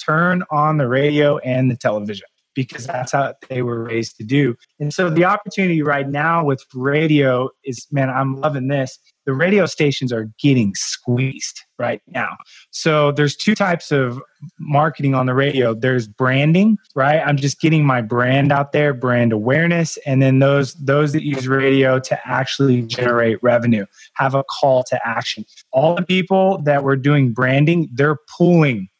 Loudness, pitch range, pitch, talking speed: -17 LUFS, 125-150 Hz, 140 Hz, 170 wpm